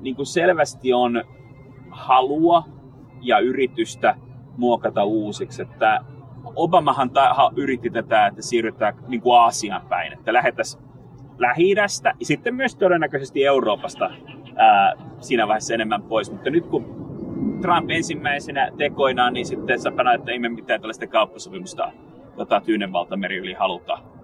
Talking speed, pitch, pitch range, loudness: 125 wpm, 135 Hz, 125-170 Hz, -20 LUFS